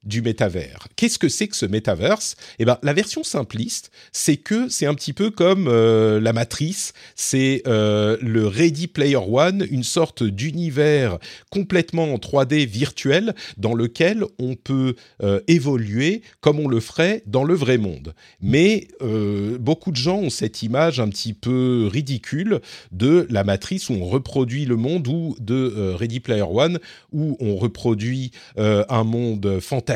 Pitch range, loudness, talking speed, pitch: 110-160 Hz, -20 LUFS, 165 wpm, 130 Hz